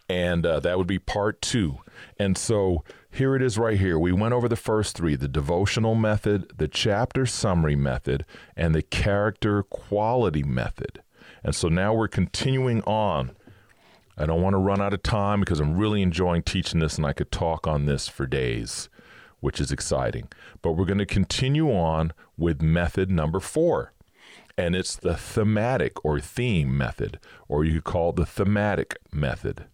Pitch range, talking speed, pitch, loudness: 80-105 Hz, 175 wpm, 95 Hz, -25 LUFS